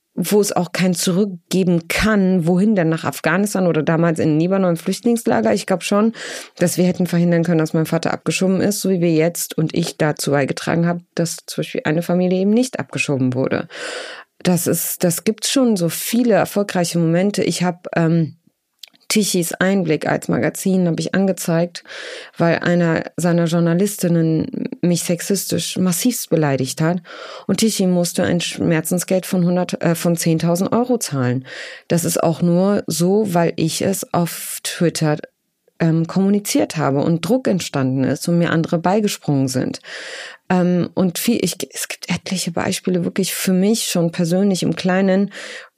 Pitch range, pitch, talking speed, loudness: 165-190 Hz, 175 Hz, 165 wpm, -18 LUFS